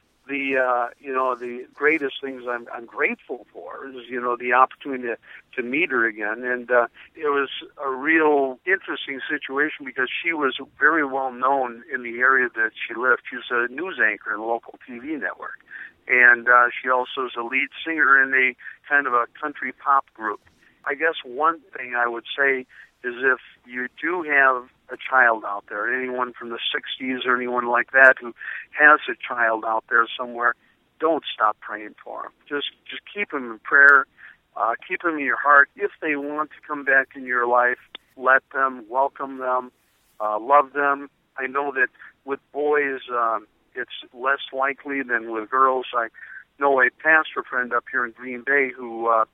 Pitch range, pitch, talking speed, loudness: 120-140 Hz, 130 Hz, 185 wpm, -21 LUFS